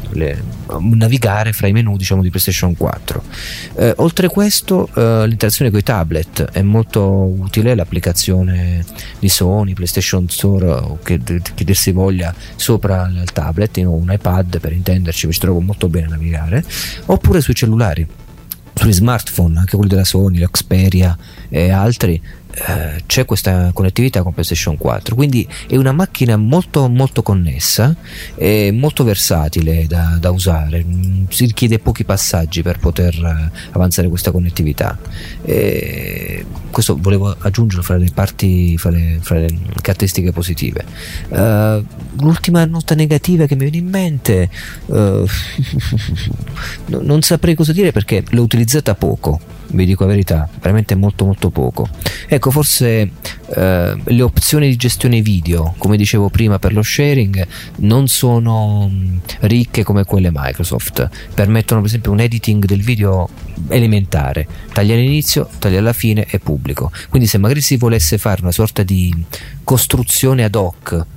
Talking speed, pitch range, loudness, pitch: 145 wpm, 90-115 Hz, -14 LUFS, 100 Hz